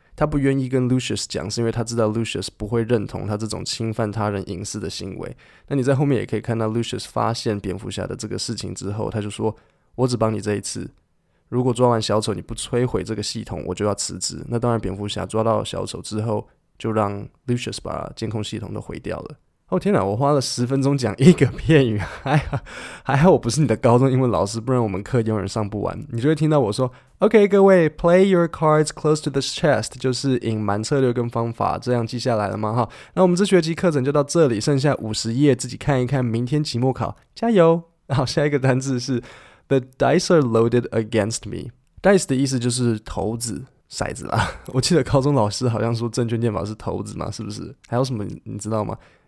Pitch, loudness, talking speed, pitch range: 120 Hz, -21 LUFS, 395 characters per minute, 110-135 Hz